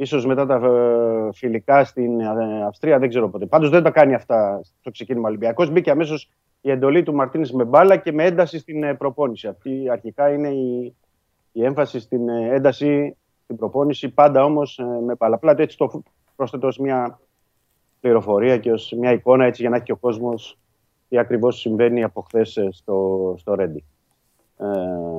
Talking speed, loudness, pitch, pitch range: 165 wpm, -19 LUFS, 125 Hz, 115-140 Hz